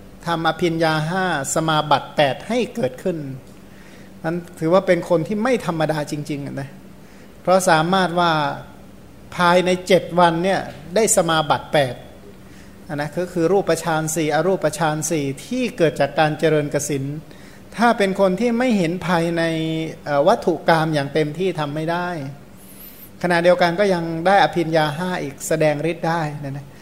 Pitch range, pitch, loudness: 150-180 Hz, 165 Hz, -19 LUFS